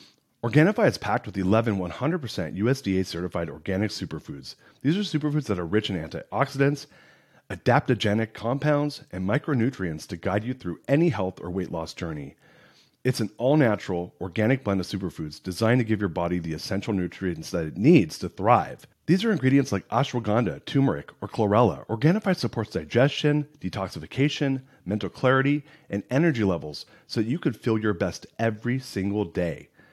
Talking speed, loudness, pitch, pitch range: 160 wpm, -26 LUFS, 110 Hz, 95-140 Hz